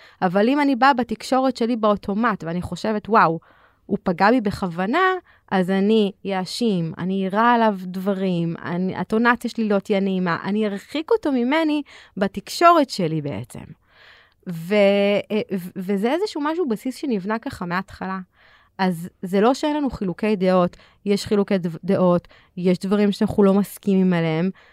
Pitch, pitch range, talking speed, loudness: 200 Hz, 185-230 Hz, 140 wpm, -21 LUFS